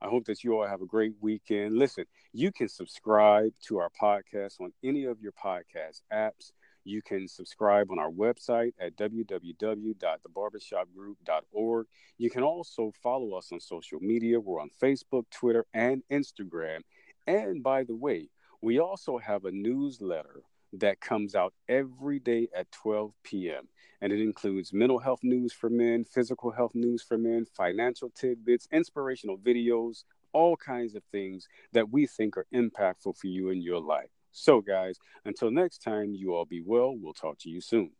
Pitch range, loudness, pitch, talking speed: 100-125 Hz, -30 LUFS, 115 Hz, 165 wpm